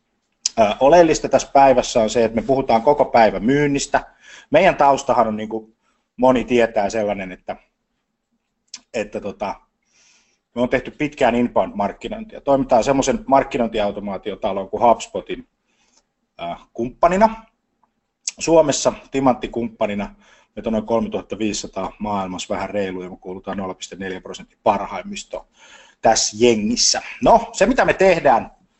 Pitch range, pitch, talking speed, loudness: 110-145 Hz, 125 Hz, 115 wpm, -18 LUFS